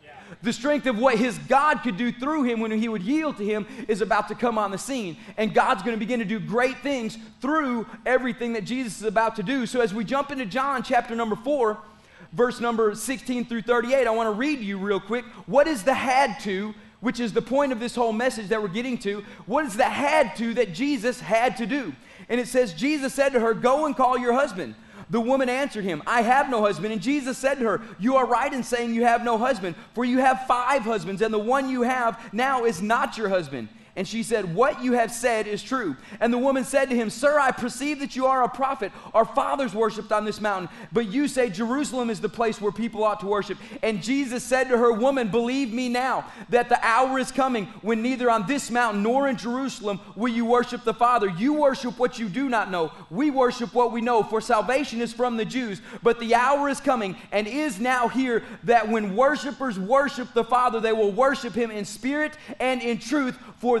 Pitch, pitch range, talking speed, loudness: 240 Hz, 220-260 Hz, 235 wpm, -24 LUFS